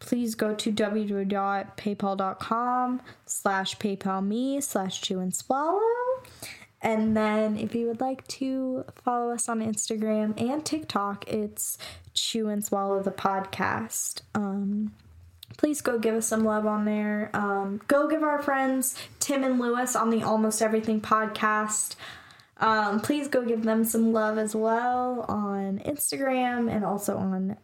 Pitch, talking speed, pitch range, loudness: 220 Hz, 140 wpm, 200-245 Hz, -27 LUFS